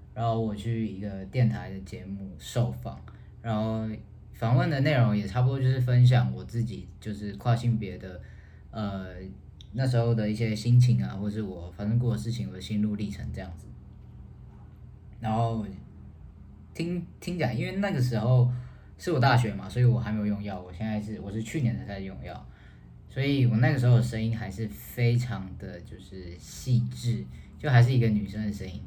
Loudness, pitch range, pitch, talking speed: -28 LUFS, 100-120 Hz, 110 Hz, 270 characters per minute